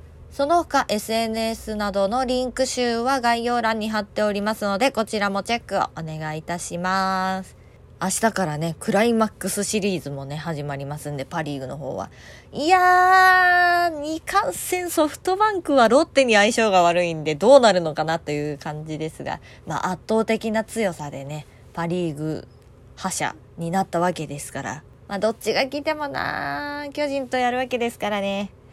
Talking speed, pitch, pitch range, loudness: 340 characters per minute, 205 Hz, 160-255 Hz, -22 LUFS